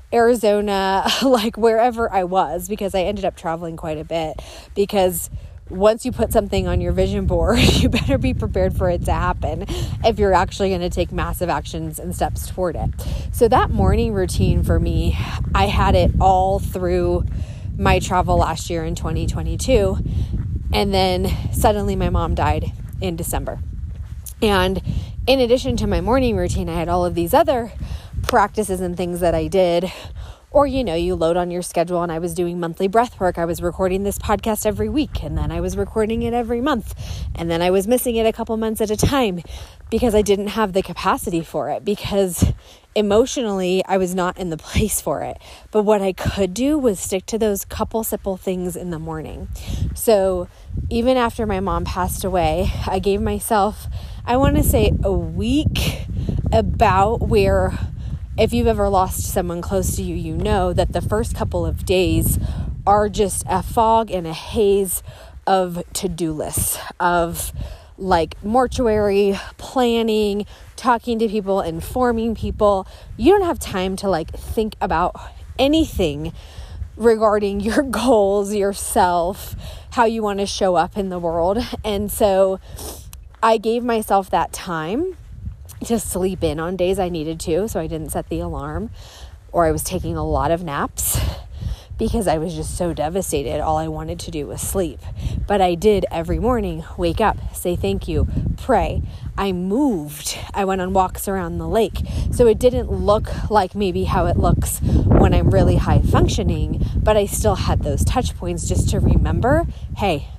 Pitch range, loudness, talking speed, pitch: 160-215 Hz, -20 LUFS, 175 wpm, 190 Hz